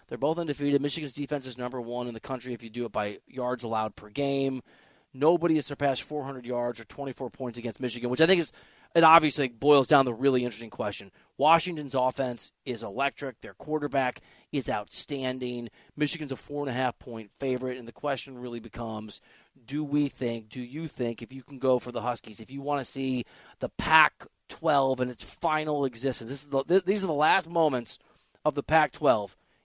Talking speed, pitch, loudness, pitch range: 200 wpm, 130 Hz, -28 LUFS, 120-145 Hz